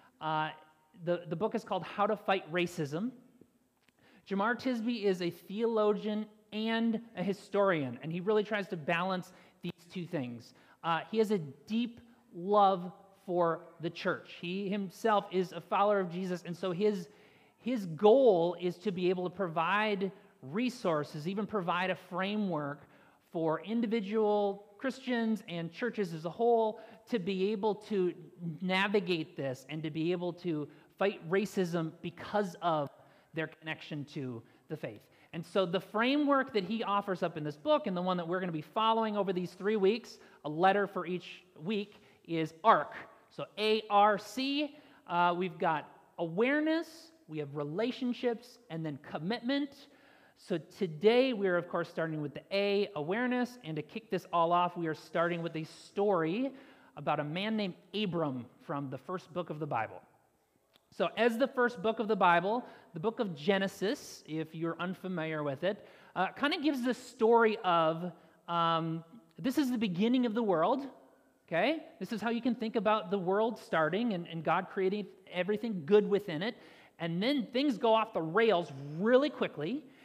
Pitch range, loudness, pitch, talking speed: 170-220 Hz, -33 LUFS, 195 Hz, 170 wpm